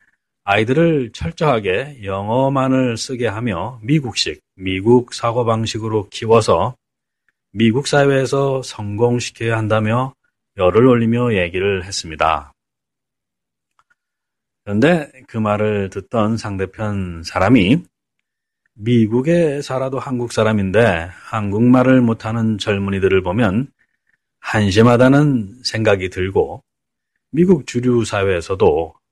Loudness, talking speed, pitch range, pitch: -17 LUFS, 235 characters per minute, 100-125 Hz, 115 Hz